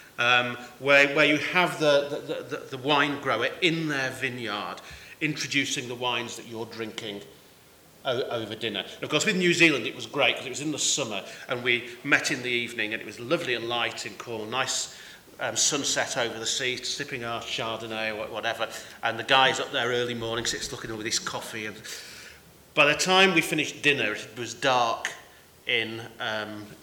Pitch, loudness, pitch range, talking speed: 125 Hz, -26 LUFS, 115-145 Hz, 195 wpm